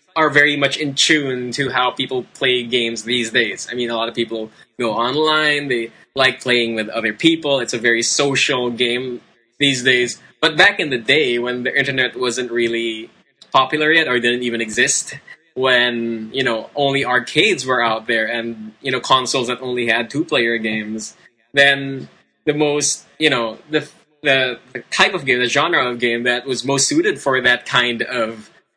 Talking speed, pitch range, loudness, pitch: 190 wpm, 115-140 Hz, -17 LUFS, 125 Hz